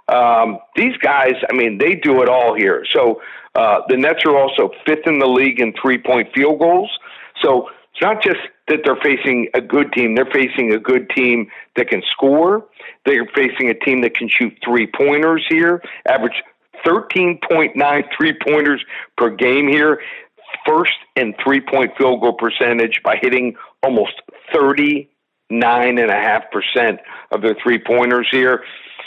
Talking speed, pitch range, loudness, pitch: 160 wpm, 120-150 Hz, -15 LUFS, 130 Hz